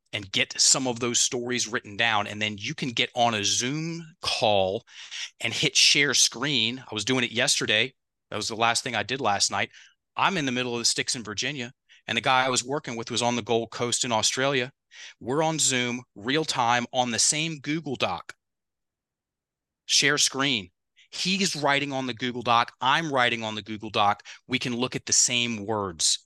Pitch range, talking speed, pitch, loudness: 115-135 Hz, 205 wpm, 125 Hz, -24 LUFS